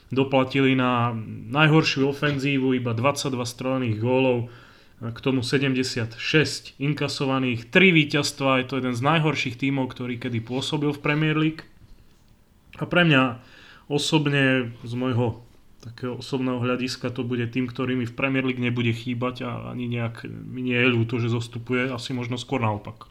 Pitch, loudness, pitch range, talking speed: 130 Hz, -23 LUFS, 120-135 Hz, 150 wpm